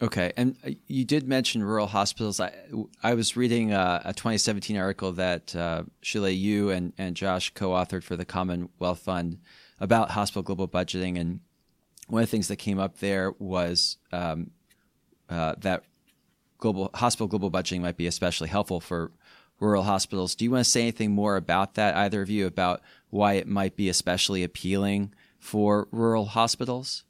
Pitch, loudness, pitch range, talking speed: 100 Hz, -27 LUFS, 90-105 Hz, 170 wpm